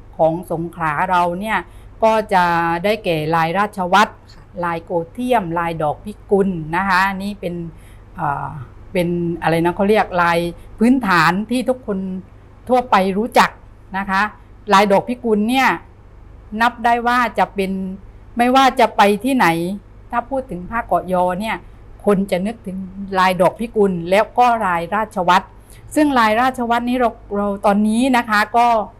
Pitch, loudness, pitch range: 195 Hz, -17 LUFS, 175-225 Hz